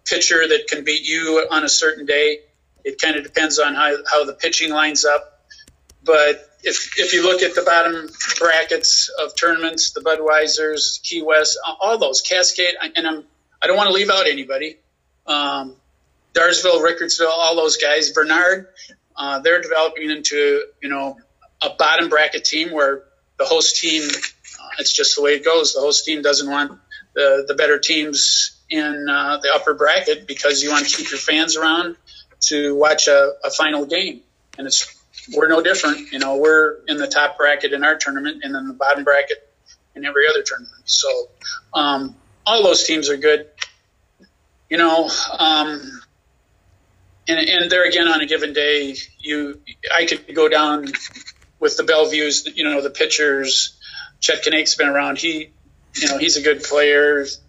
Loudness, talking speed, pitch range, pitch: -16 LUFS, 170 wpm, 145-180 Hz, 155 Hz